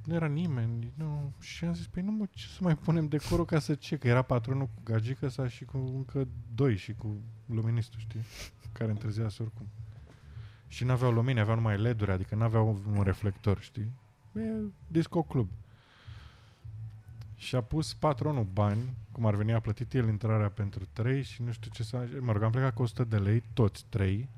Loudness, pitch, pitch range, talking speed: -32 LUFS, 115 Hz, 110-135 Hz, 195 wpm